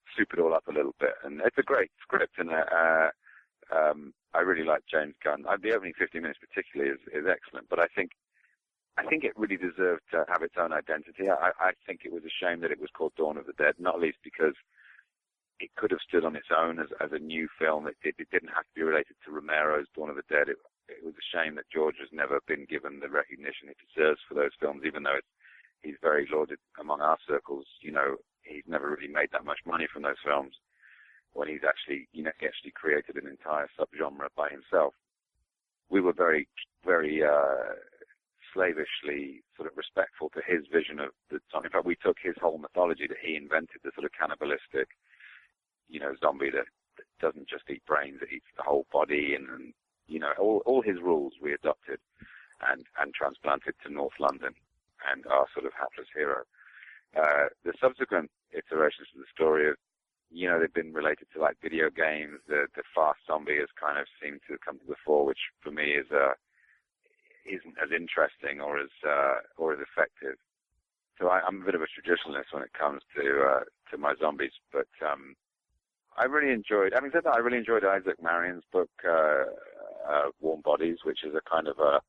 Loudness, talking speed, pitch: -30 LUFS, 210 wpm, 85 Hz